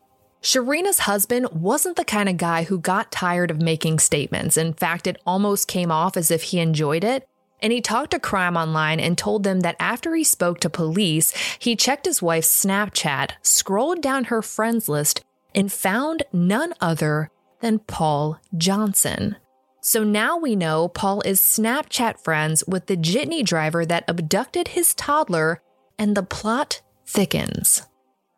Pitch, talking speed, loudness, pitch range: 190 Hz, 160 wpm, -20 LUFS, 165-230 Hz